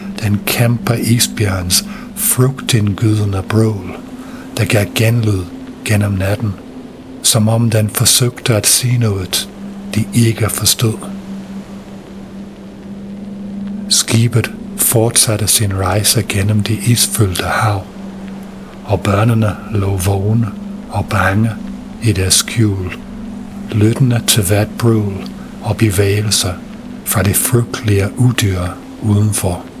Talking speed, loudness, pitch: 95 wpm, -14 LUFS, 115 Hz